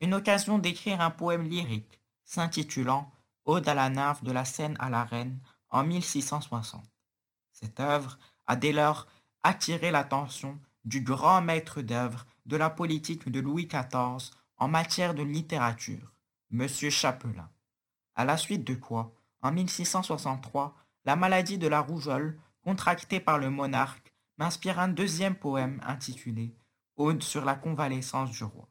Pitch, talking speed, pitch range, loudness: 140 Hz, 145 wpm, 125-160 Hz, -30 LUFS